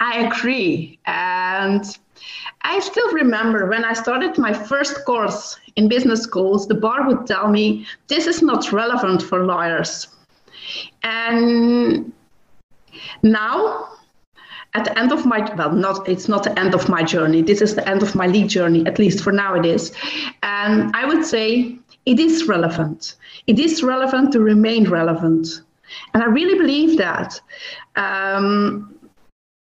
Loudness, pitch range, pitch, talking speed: -18 LUFS, 190-250 Hz, 215 Hz, 150 wpm